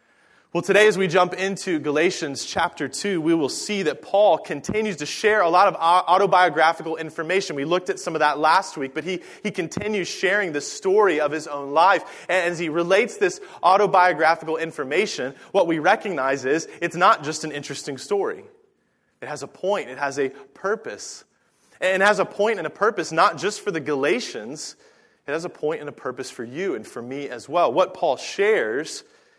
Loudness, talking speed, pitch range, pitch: -22 LUFS, 195 wpm, 160-215 Hz, 185 Hz